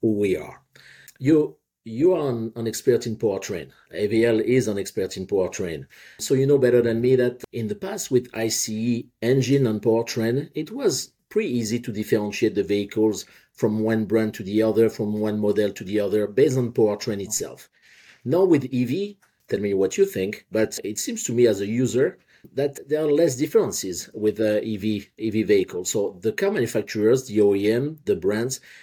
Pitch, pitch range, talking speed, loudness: 115 Hz, 105-135 Hz, 185 wpm, -23 LUFS